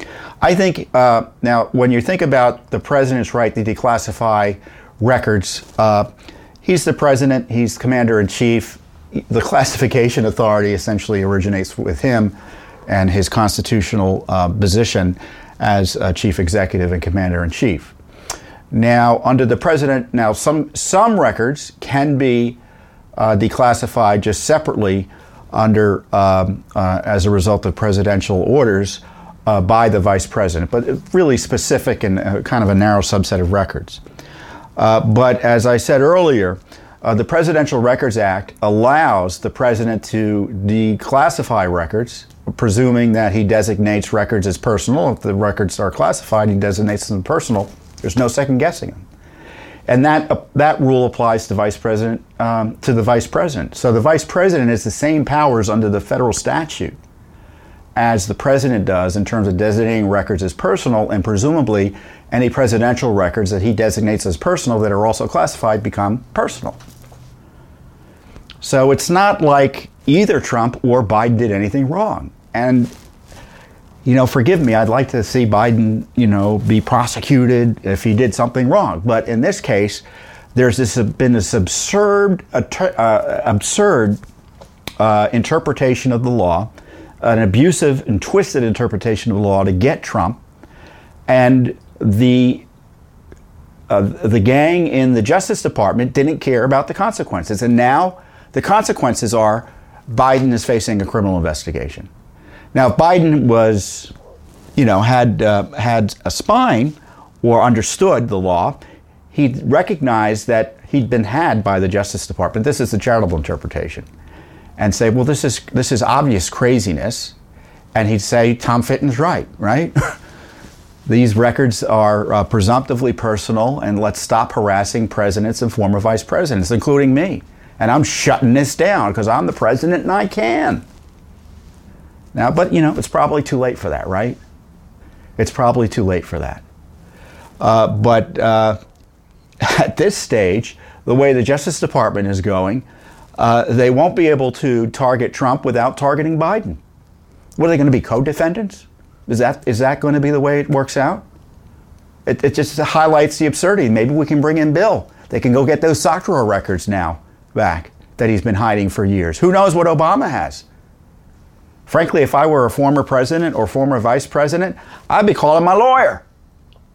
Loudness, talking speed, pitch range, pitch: -15 LUFS, 155 wpm, 100-130 Hz, 115 Hz